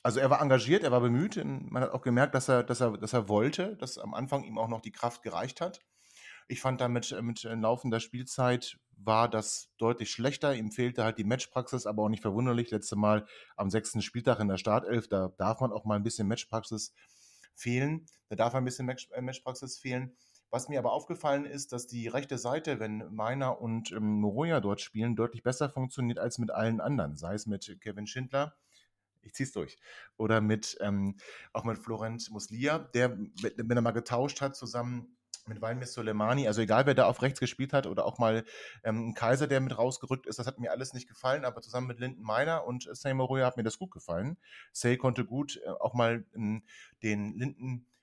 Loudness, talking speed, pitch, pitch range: -32 LUFS, 200 wpm, 120 Hz, 110-130 Hz